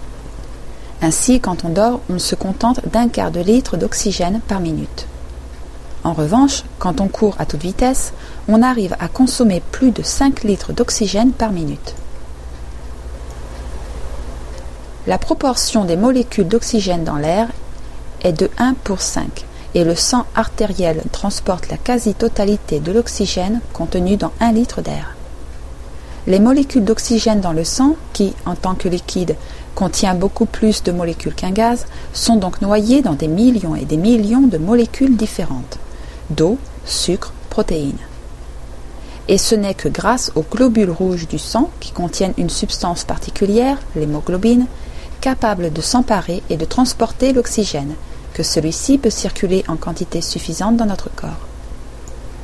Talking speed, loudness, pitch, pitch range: 145 wpm, -17 LUFS, 190 Hz, 145-230 Hz